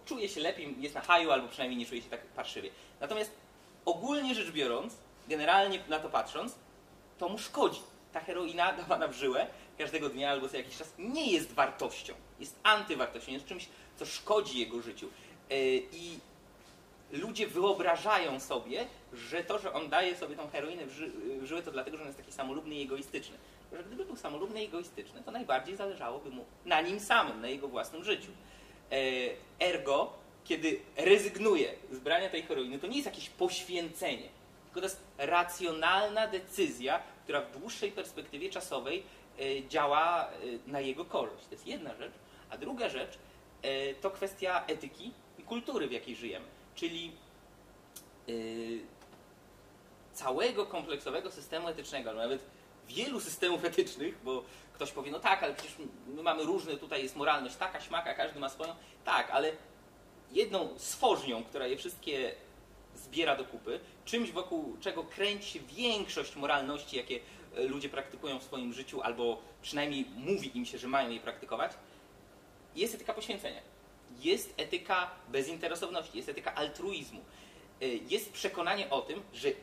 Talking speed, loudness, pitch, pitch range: 150 wpm, -35 LUFS, 175 Hz, 135-225 Hz